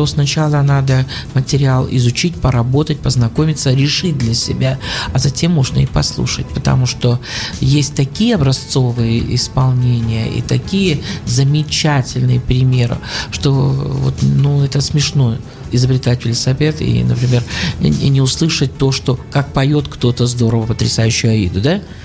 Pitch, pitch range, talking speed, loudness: 130 Hz, 120-140 Hz, 125 wpm, -14 LUFS